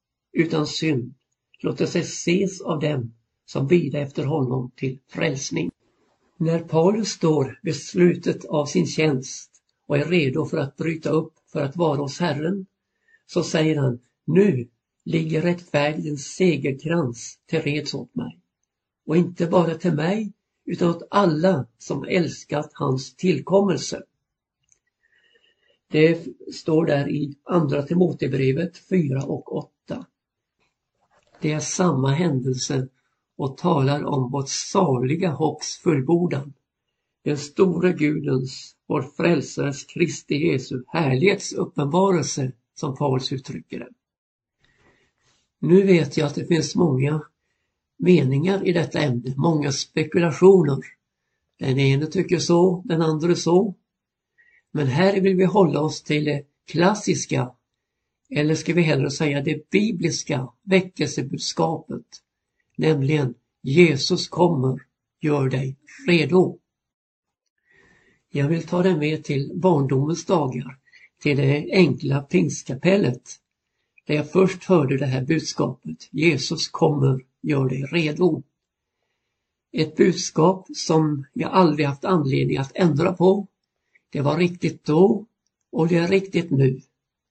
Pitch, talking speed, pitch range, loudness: 155 Hz, 120 wpm, 140-175 Hz, -22 LUFS